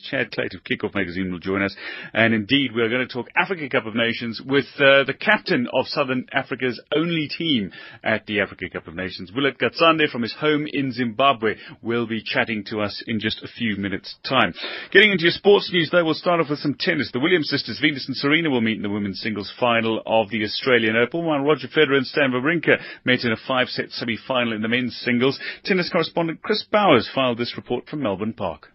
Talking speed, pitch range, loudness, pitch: 220 wpm, 110-150 Hz, -21 LUFS, 125 Hz